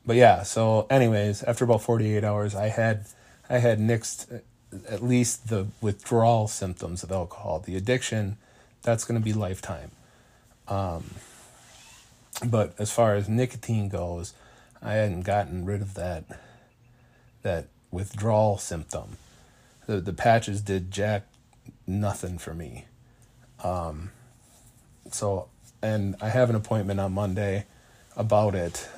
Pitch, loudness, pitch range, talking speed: 105 Hz, -26 LUFS, 100-120 Hz, 130 wpm